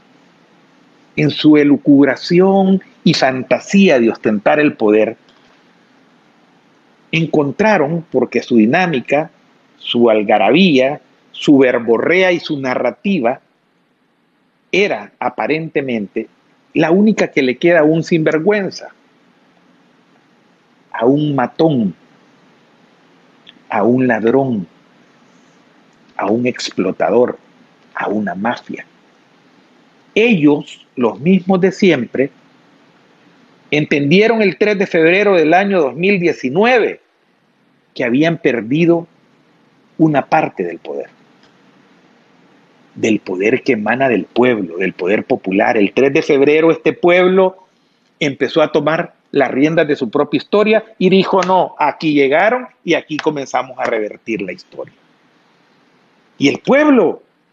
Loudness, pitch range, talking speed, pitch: -14 LUFS, 135-190 Hz, 105 wpm, 160 Hz